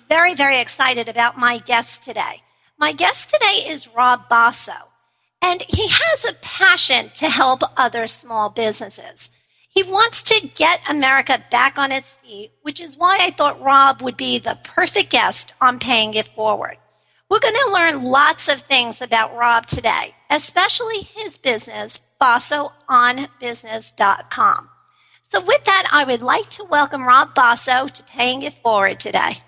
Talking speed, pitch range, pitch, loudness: 155 wpm, 240-340 Hz, 270 Hz, -16 LUFS